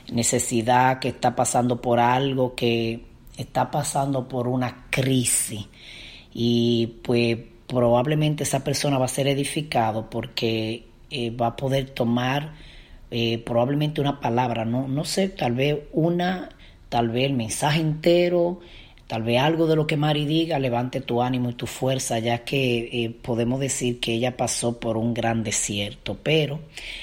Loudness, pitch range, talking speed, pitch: -23 LUFS, 120-140 Hz, 155 wpm, 125 Hz